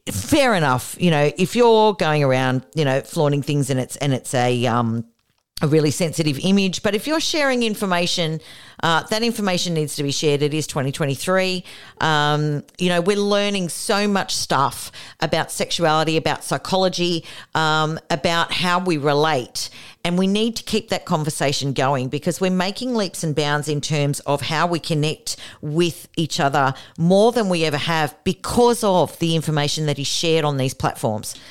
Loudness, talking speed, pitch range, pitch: -20 LUFS, 175 wpm, 145-185 Hz, 155 Hz